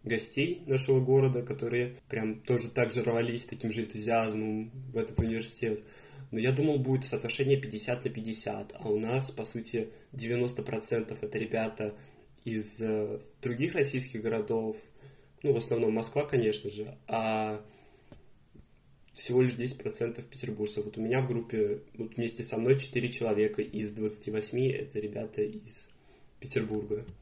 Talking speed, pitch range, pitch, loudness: 140 wpm, 110-130 Hz, 115 Hz, -30 LUFS